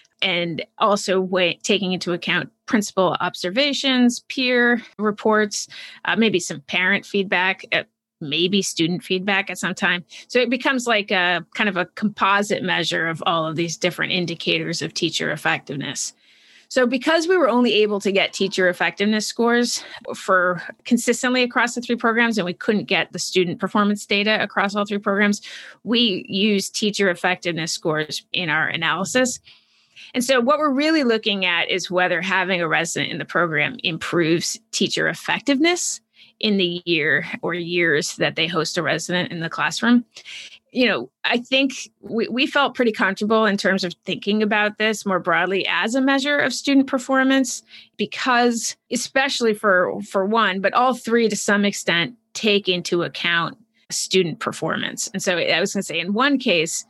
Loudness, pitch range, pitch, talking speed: -20 LUFS, 180-240 Hz, 200 Hz, 165 wpm